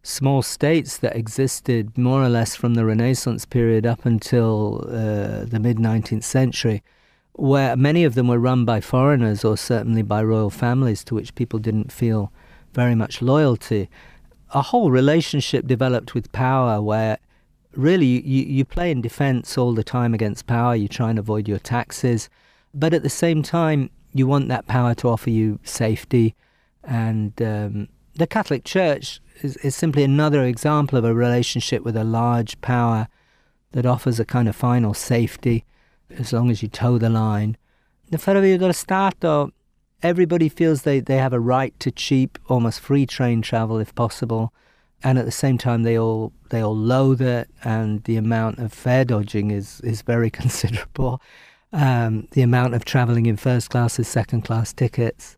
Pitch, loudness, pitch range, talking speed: 120 Hz, -20 LUFS, 115-135 Hz, 170 wpm